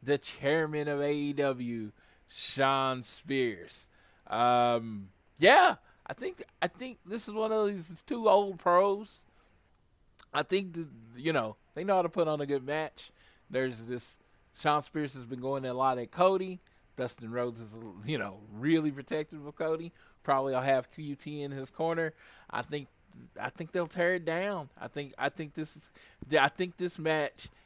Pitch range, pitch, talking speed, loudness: 130-170 Hz, 150 Hz, 175 wpm, -31 LUFS